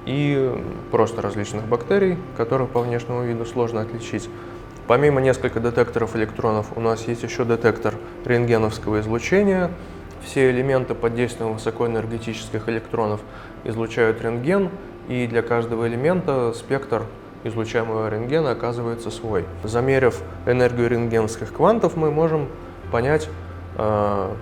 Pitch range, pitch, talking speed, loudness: 110-125 Hz, 115 Hz, 110 wpm, -22 LUFS